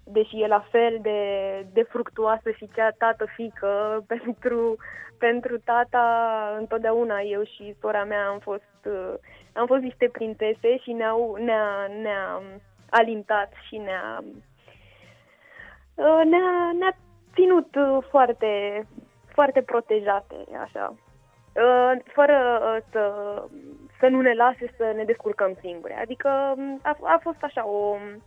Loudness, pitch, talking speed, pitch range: -24 LUFS, 225 Hz, 115 wpm, 205-245 Hz